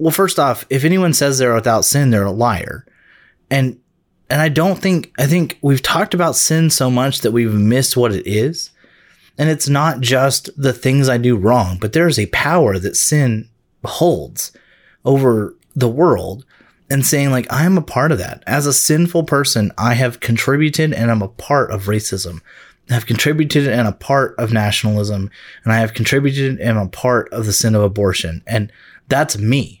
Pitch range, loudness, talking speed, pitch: 110-145 Hz, -15 LUFS, 195 wpm, 125 Hz